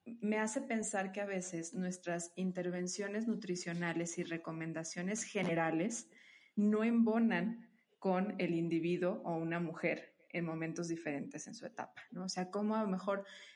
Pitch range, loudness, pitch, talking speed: 170-215 Hz, -38 LUFS, 185 Hz, 145 wpm